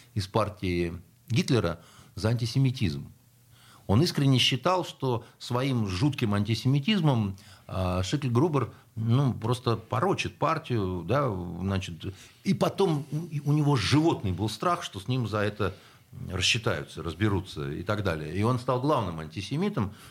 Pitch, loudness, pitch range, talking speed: 120 Hz, -28 LUFS, 100-135 Hz, 120 wpm